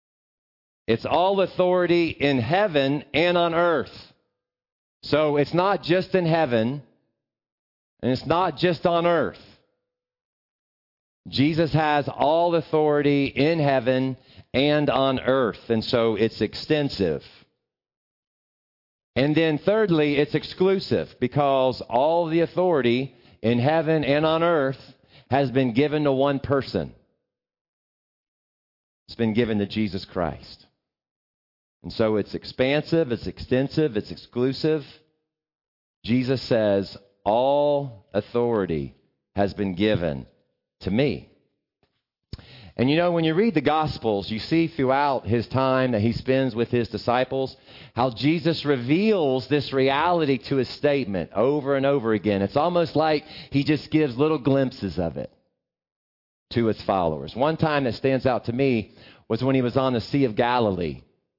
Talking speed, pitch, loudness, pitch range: 135 wpm, 135 Hz, -23 LUFS, 115-155 Hz